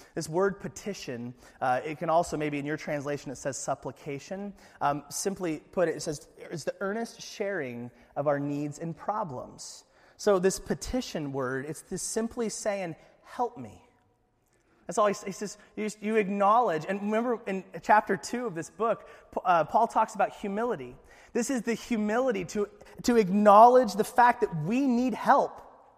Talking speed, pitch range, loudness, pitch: 170 wpm, 160-225 Hz, -28 LUFS, 200 Hz